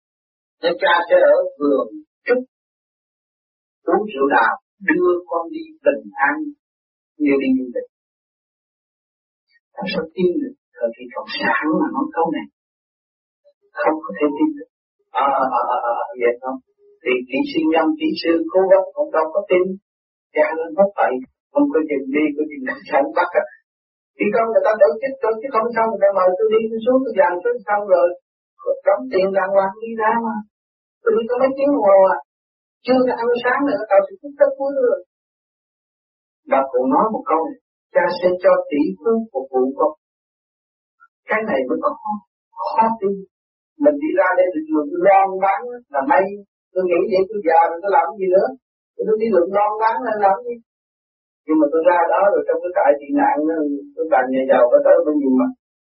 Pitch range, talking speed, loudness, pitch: 175-285 Hz, 205 wpm, -18 LUFS, 220 Hz